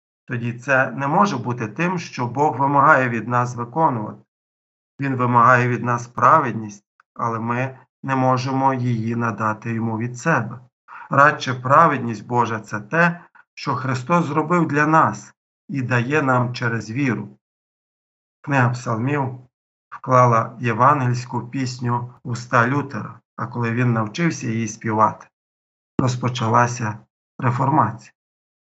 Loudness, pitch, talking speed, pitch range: -20 LUFS, 125 Hz, 120 wpm, 115-135 Hz